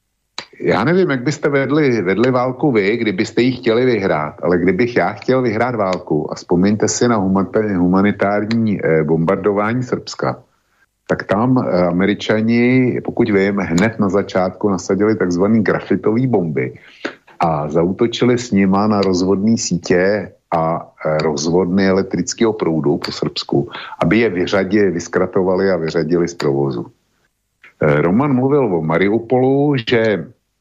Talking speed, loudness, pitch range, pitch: 125 wpm, -16 LUFS, 90-120 Hz, 105 Hz